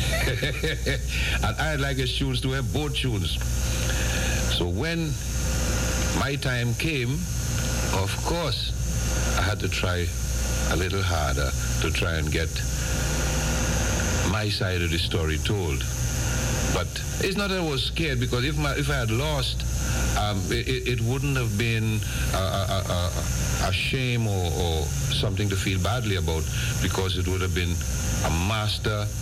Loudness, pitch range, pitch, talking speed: -25 LUFS, 75-120 Hz, 95 Hz, 150 wpm